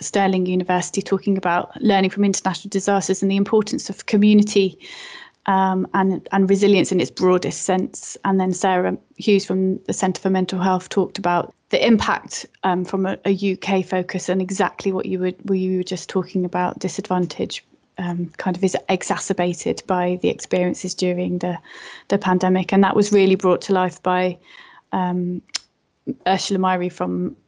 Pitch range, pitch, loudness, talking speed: 180-195 Hz, 185 Hz, -20 LUFS, 170 wpm